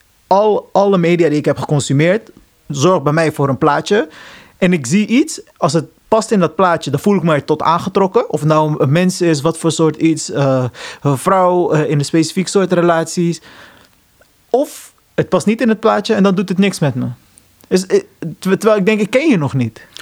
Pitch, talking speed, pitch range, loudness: 170 Hz, 215 wpm, 155-200 Hz, -14 LUFS